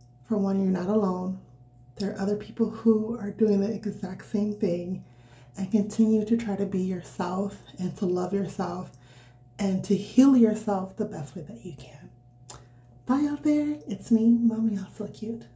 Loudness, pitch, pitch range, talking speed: -27 LUFS, 200 Hz, 180-215 Hz, 175 wpm